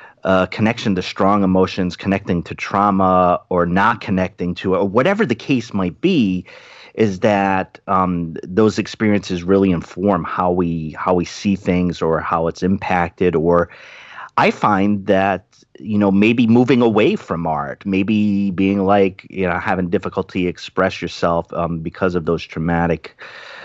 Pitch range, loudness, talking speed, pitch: 90-100 Hz, -18 LUFS, 150 wpm, 95 Hz